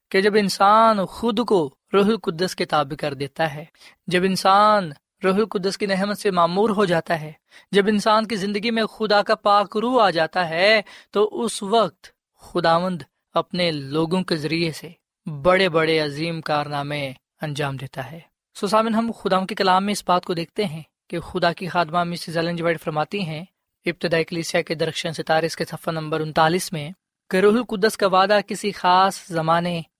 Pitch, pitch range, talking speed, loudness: 180 Hz, 165-205 Hz, 175 wpm, -21 LUFS